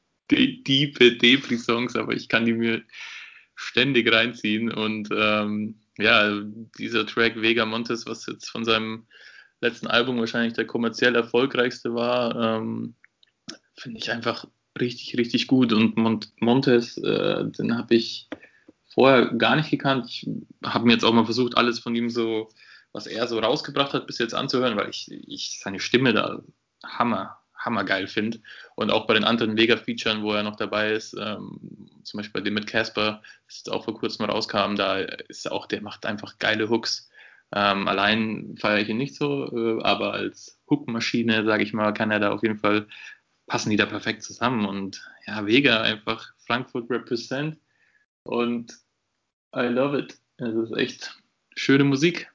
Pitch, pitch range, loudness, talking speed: 115 Hz, 110-120 Hz, -23 LUFS, 165 wpm